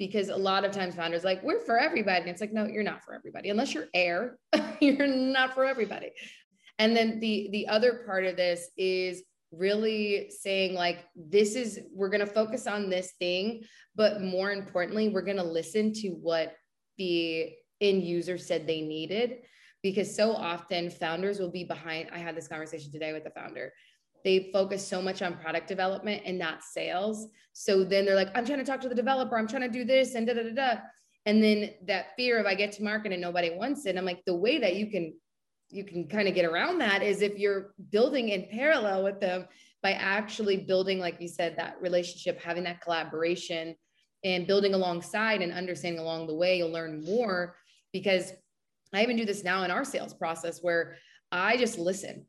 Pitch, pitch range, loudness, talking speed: 195 Hz, 175-215 Hz, -29 LUFS, 200 wpm